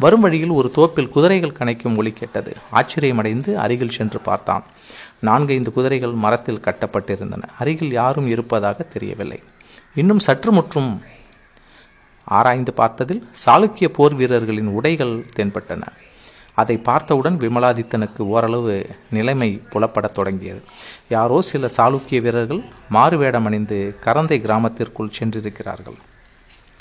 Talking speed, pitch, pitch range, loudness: 105 wpm, 120 Hz, 110-140 Hz, -18 LUFS